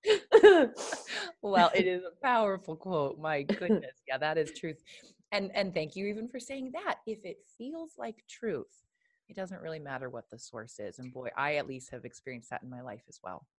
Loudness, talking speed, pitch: -30 LUFS, 205 wpm, 190 Hz